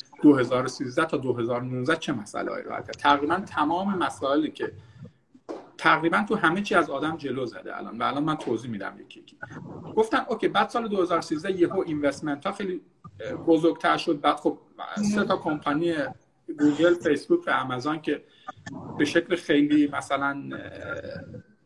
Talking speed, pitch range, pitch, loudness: 145 wpm, 145-190 Hz, 165 Hz, -25 LUFS